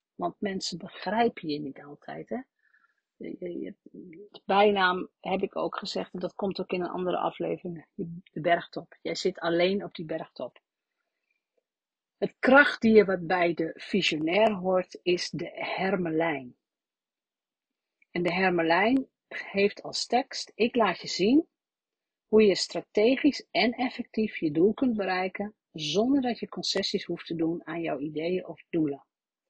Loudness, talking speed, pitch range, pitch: -27 LUFS, 140 wpm, 170-215 Hz, 185 Hz